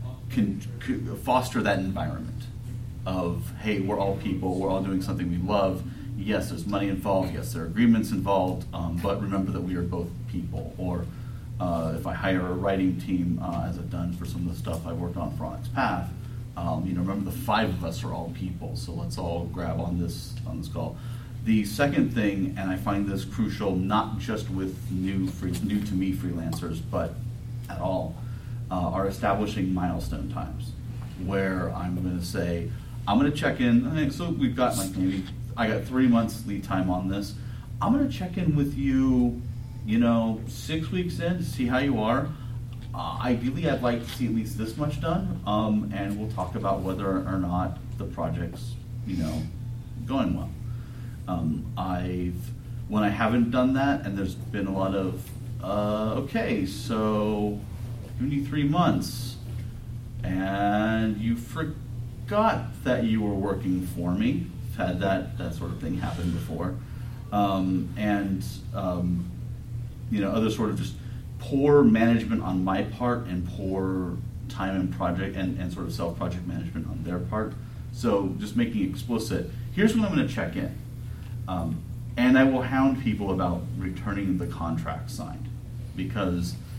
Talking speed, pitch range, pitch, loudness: 175 wpm, 95-120 Hz, 110 Hz, -28 LUFS